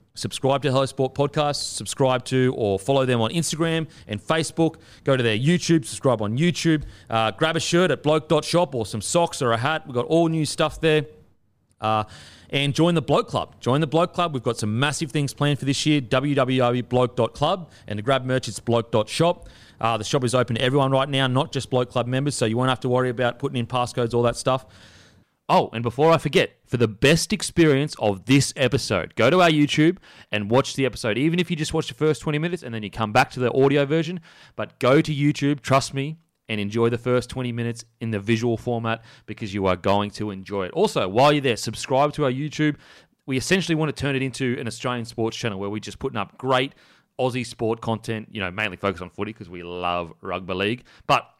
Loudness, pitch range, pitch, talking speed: -23 LUFS, 115-150 Hz, 130 Hz, 225 wpm